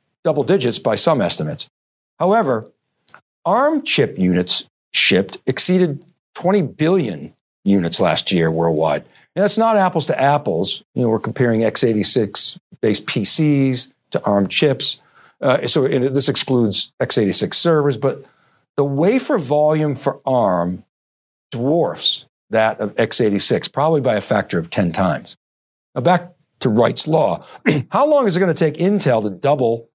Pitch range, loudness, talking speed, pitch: 105-175 Hz, -16 LUFS, 140 wpm, 140 Hz